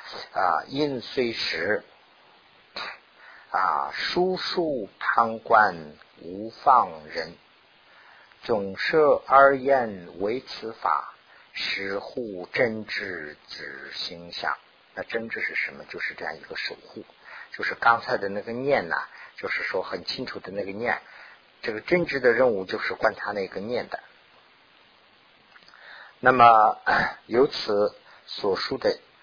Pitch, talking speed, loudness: 175 Hz, 170 characters per minute, -25 LUFS